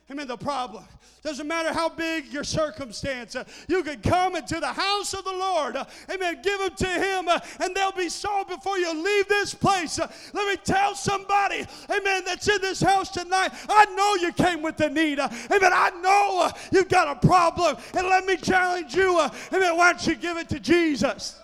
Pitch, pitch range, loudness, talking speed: 350 Hz, 315-380 Hz, -23 LUFS, 215 wpm